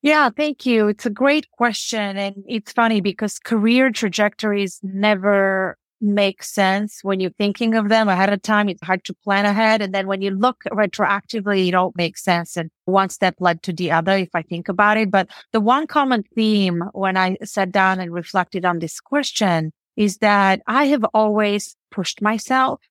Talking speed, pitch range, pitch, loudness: 190 wpm, 190-220 Hz, 205 Hz, -19 LUFS